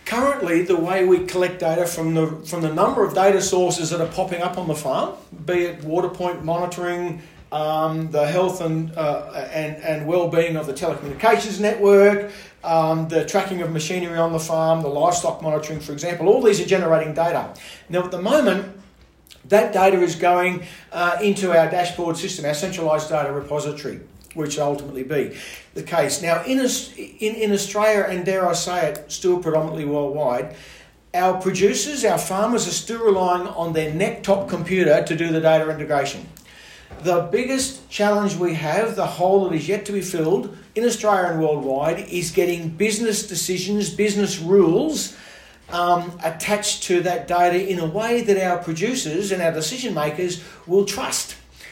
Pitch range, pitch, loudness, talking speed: 160-195 Hz, 175 Hz, -21 LUFS, 175 wpm